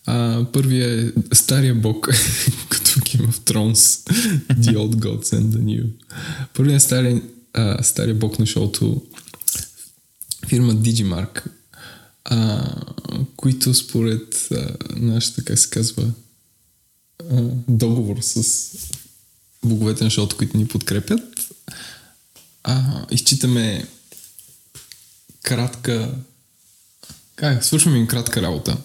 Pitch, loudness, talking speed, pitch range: 120 Hz, -18 LUFS, 105 wpm, 110-130 Hz